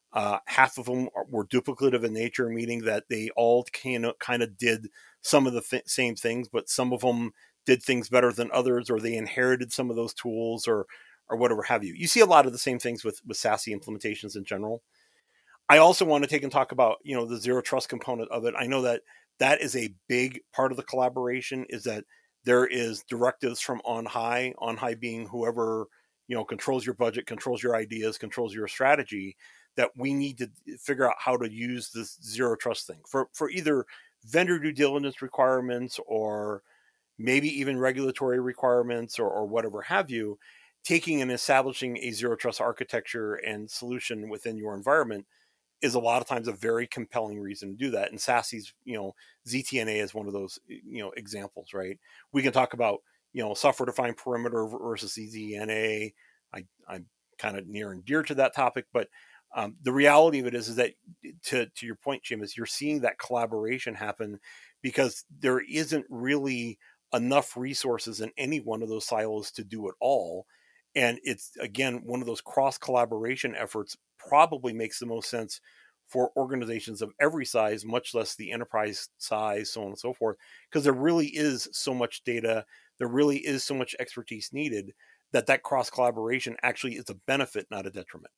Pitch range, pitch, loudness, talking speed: 110-130 Hz, 120 Hz, -28 LUFS, 195 wpm